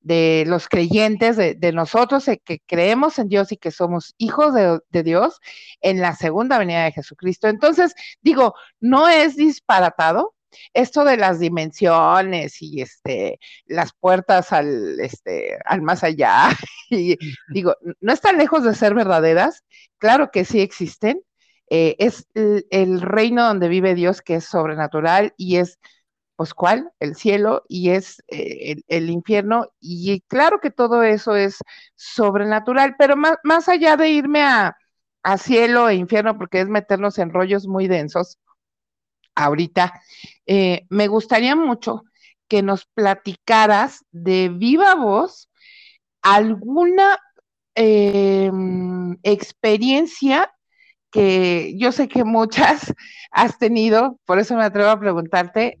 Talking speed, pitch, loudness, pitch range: 135 wpm, 210 Hz, -17 LUFS, 180-270 Hz